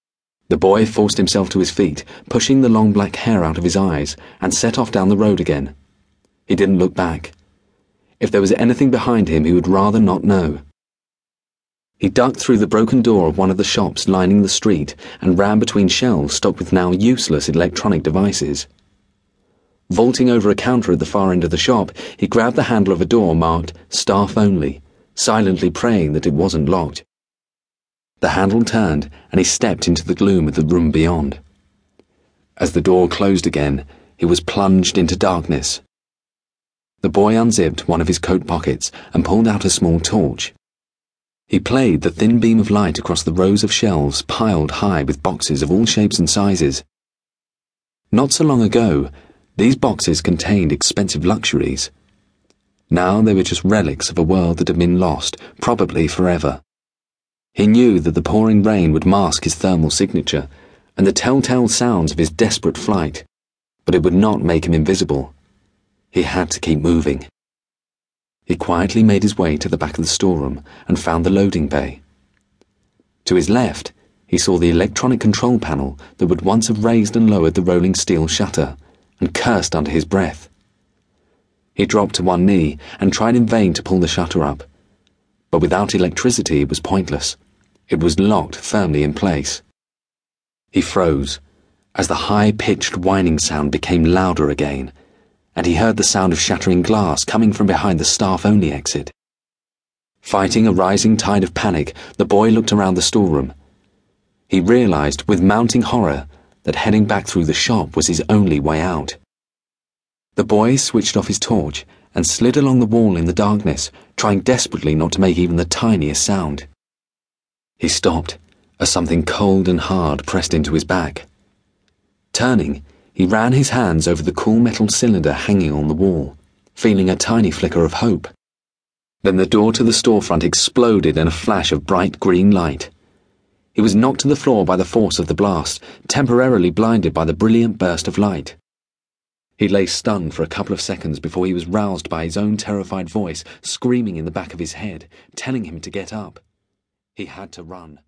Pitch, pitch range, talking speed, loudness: 95 Hz, 80-105 Hz, 180 wpm, -16 LUFS